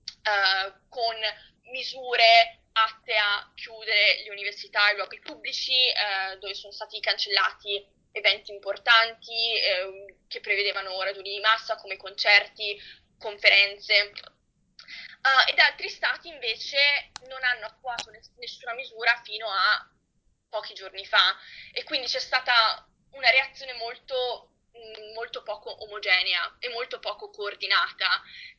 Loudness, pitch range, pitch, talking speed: -23 LUFS, 205-255 Hz, 220 Hz, 120 wpm